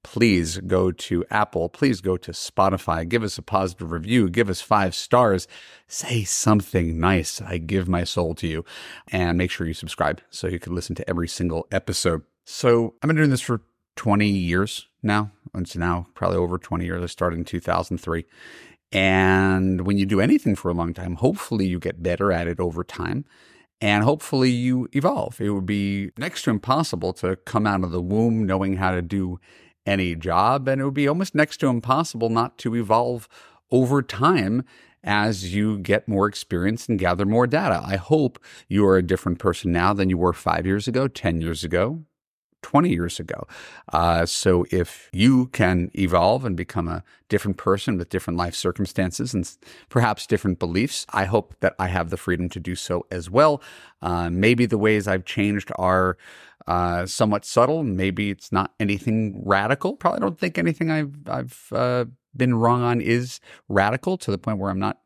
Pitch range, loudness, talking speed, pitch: 90-120 Hz, -23 LUFS, 185 wpm, 100 Hz